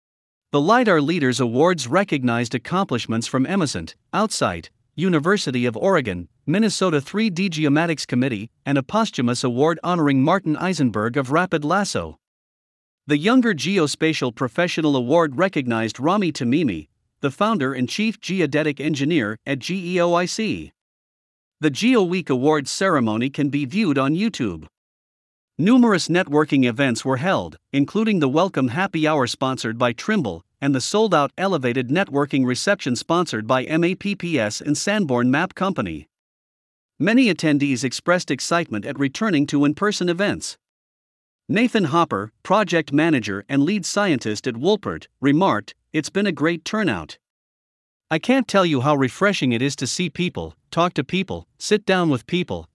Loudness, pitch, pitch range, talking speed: -20 LUFS, 150 Hz, 130-185 Hz, 140 wpm